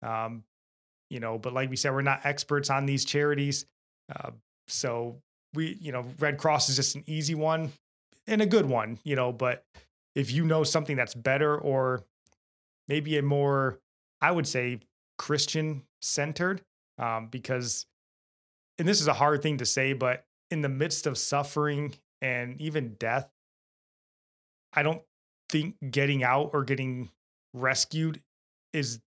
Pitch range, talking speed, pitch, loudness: 125-150 Hz, 155 wpm, 140 Hz, -28 LUFS